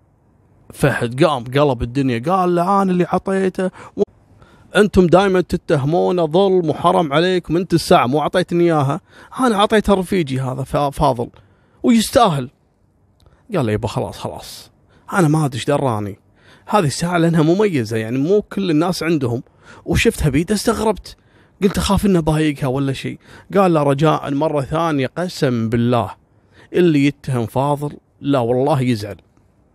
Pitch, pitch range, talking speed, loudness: 150 Hz, 125-180 Hz, 135 wpm, -17 LUFS